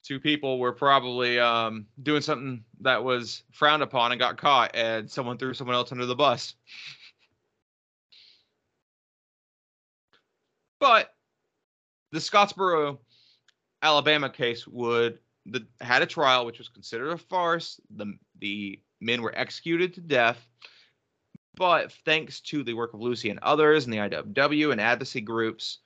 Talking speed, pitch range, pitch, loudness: 135 wpm, 115-150 Hz, 125 Hz, -25 LUFS